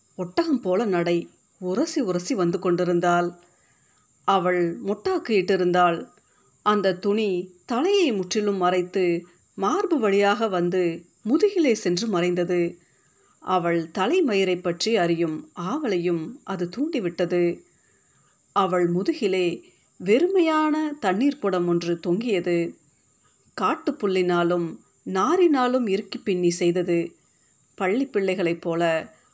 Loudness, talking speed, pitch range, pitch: -23 LUFS, 85 wpm, 175-225 Hz, 185 Hz